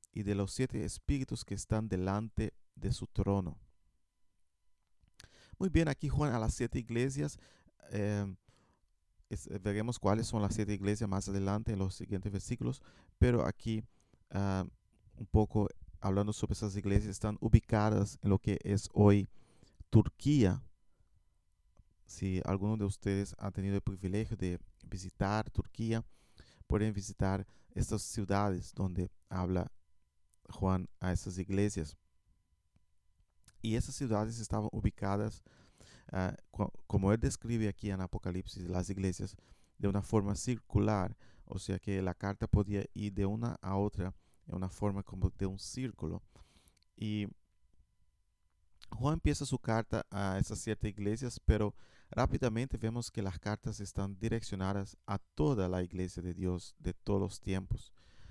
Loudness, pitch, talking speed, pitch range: -36 LUFS, 100 Hz, 140 wpm, 90-110 Hz